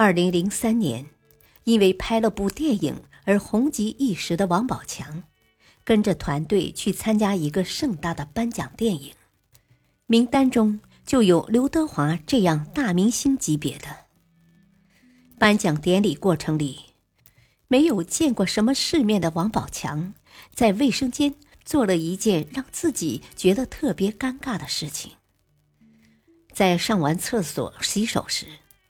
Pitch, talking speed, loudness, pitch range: 195 Hz, 210 characters per minute, -23 LUFS, 165-235 Hz